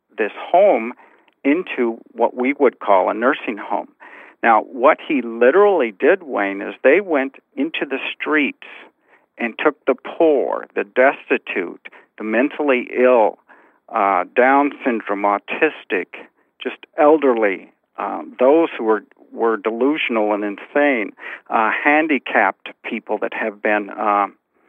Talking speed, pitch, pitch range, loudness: 125 wpm, 120 Hz, 105-145 Hz, -18 LUFS